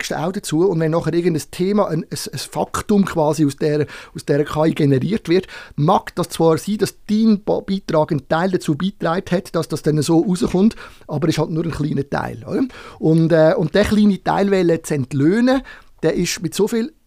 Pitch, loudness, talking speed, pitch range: 165 Hz, -18 LUFS, 200 wpm, 155-195 Hz